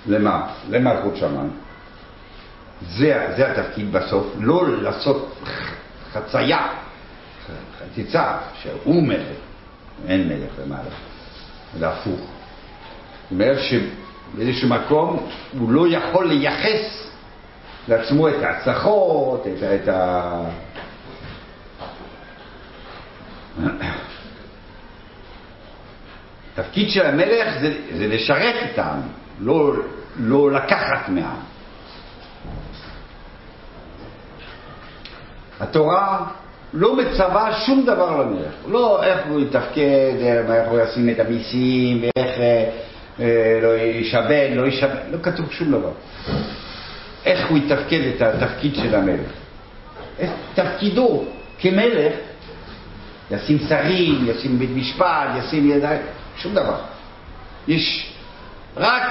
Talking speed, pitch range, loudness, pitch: 90 wpm, 115-165 Hz, -20 LUFS, 135 Hz